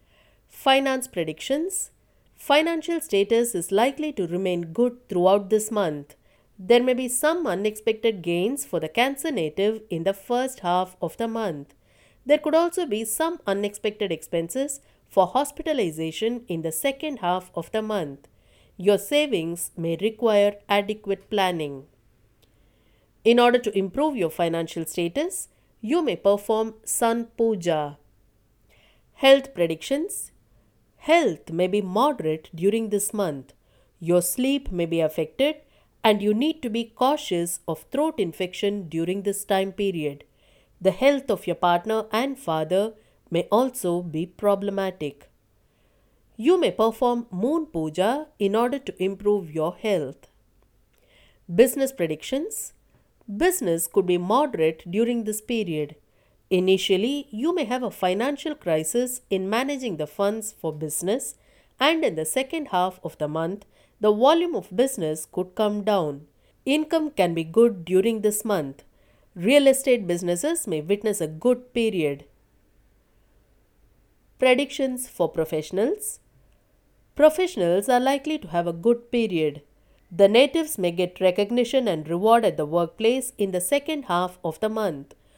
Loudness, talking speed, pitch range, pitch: -24 LUFS, 135 wpm, 170-245 Hz, 200 Hz